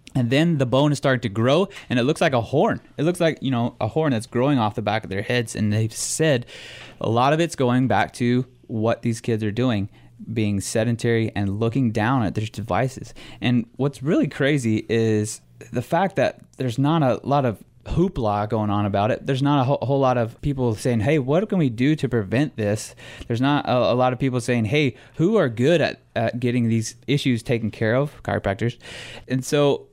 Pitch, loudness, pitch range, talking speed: 125 Hz, -22 LUFS, 110-140 Hz, 215 wpm